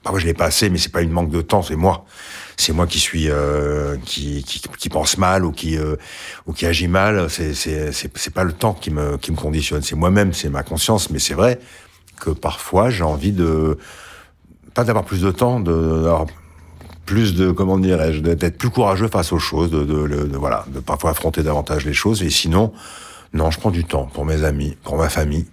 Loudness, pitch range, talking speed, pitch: -19 LUFS, 75-95 Hz, 230 wpm, 80 Hz